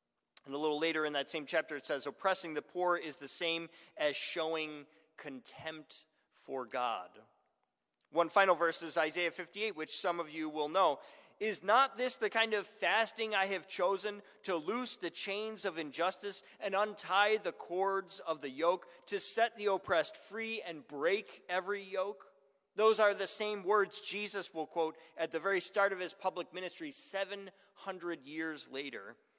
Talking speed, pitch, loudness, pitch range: 170 wpm, 185 Hz, -35 LUFS, 160-205 Hz